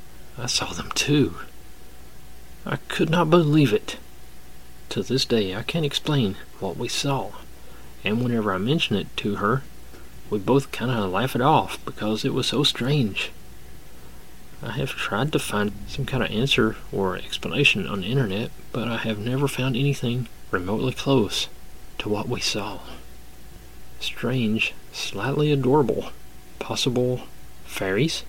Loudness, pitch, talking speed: -24 LUFS, 115 Hz, 145 wpm